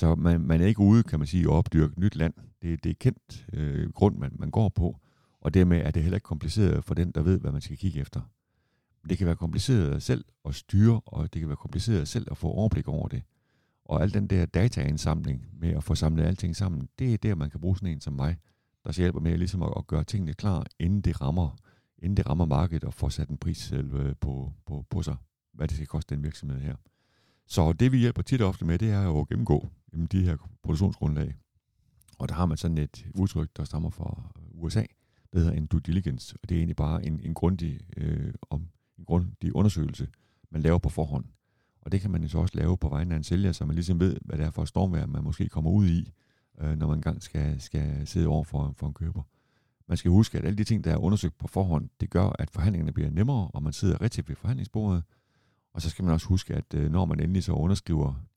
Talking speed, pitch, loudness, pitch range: 245 wpm, 85 Hz, -28 LUFS, 75-95 Hz